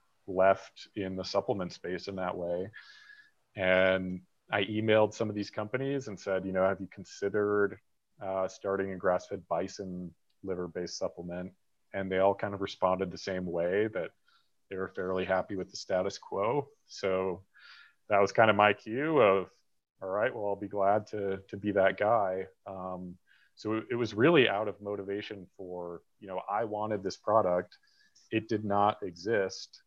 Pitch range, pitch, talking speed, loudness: 95-105 Hz, 95 Hz, 175 wpm, -31 LUFS